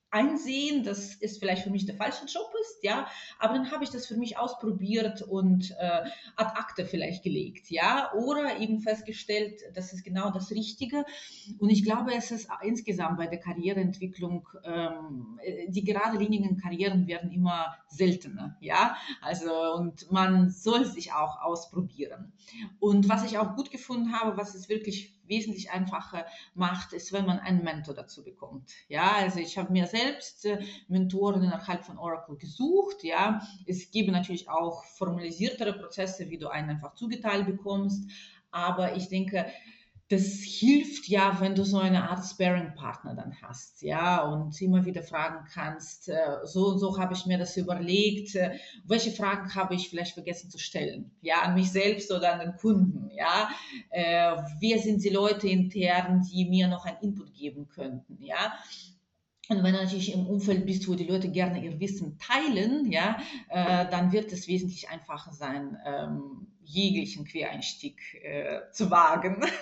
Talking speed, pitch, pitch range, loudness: 165 wpm, 190 Hz, 175-210 Hz, -29 LUFS